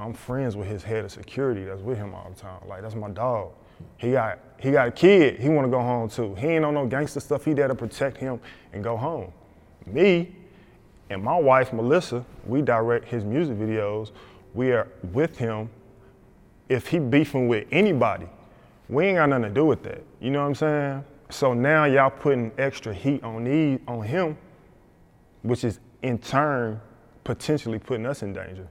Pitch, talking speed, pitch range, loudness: 125 Hz, 190 wpm, 110-140 Hz, -24 LUFS